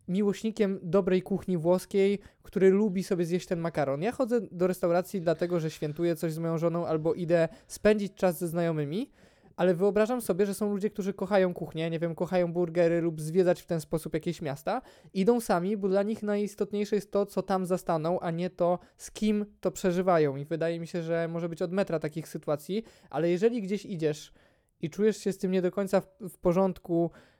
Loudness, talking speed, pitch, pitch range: -29 LUFS, 200 wpm, 180 Hz, 170-200 Hz